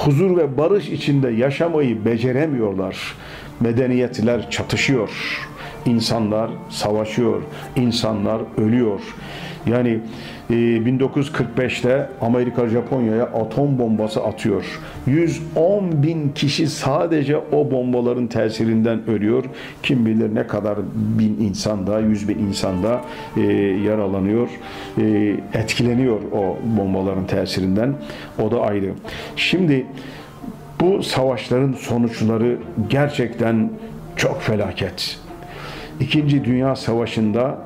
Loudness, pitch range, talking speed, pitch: -20 LUFS, 110-135 Hz, 90 wpm, 115 Hz